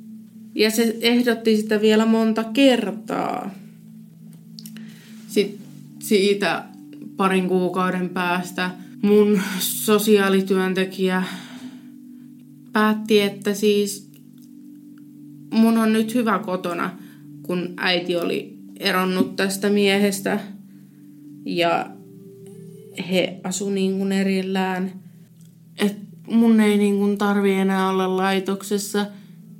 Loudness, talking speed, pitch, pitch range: -21 LUFS, 85 wpm, 200 Hz, 185-215 Hz